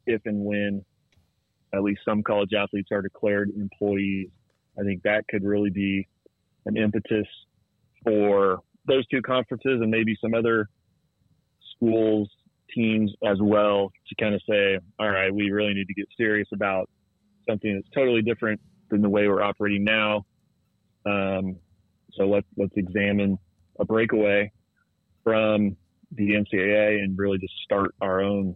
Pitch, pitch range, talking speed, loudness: 105 Hz, 100-110 Hz, 145 wpm, -25 LUFS